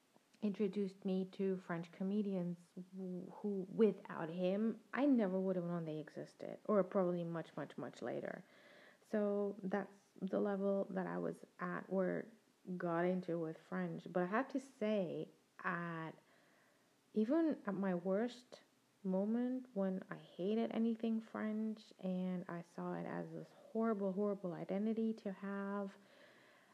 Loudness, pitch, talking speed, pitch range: -41 LUFS, 195 Hz, 135 wpm, 180-215 Hz